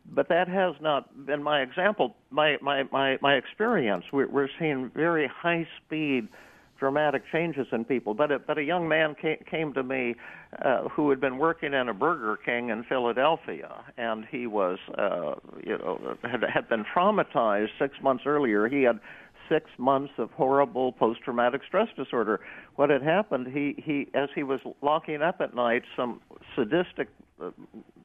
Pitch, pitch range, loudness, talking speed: 140 Hz, 130-155 Hz, -27 LUFS, 175 wpm